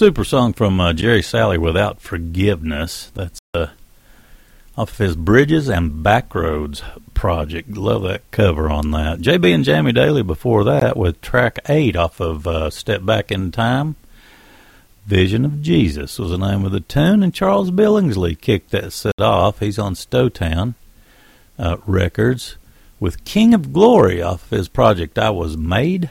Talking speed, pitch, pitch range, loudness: 160 wpm, 100 Hz, 85-125 Hz, -17 LUFS